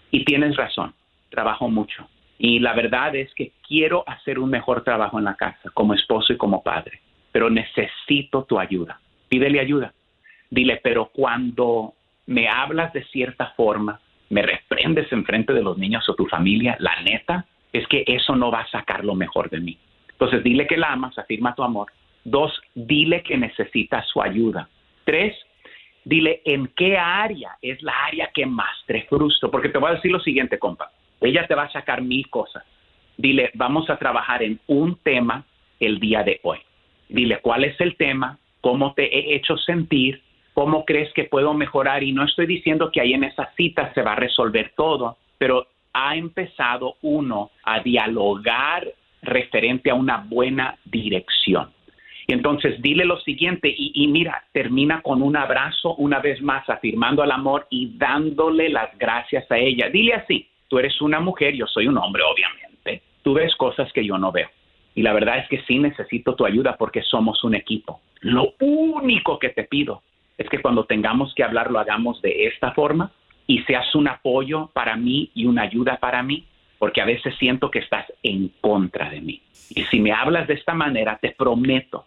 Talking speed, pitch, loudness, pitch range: 185 wpm, 135 Hz, -20 LUFS, 120-155 Hz